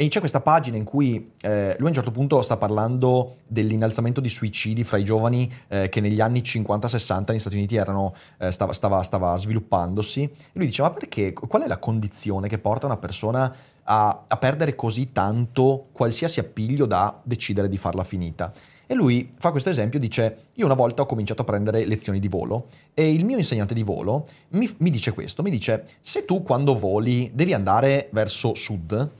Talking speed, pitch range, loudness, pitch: 195 wpm, 105-135 Hz, -23 LUFS, 115 Hz